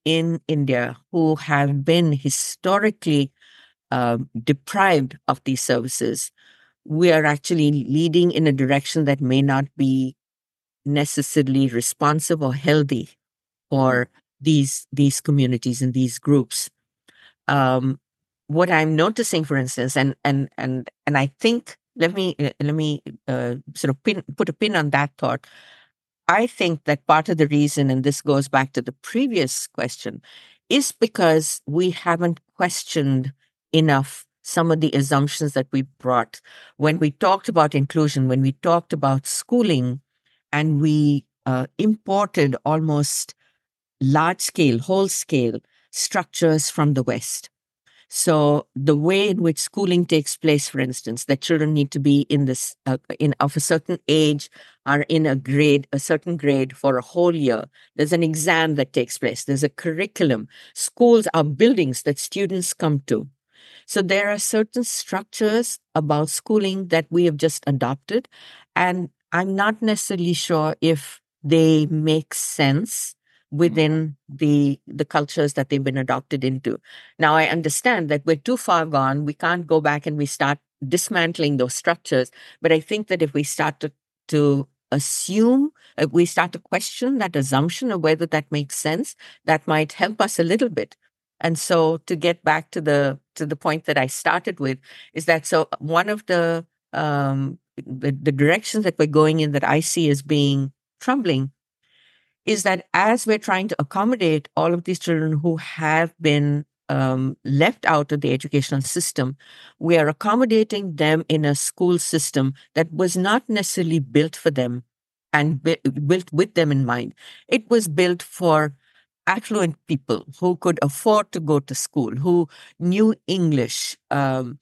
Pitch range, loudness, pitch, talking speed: 140-175 Hz, -21 LUFS, 155 Hz, 160 wpm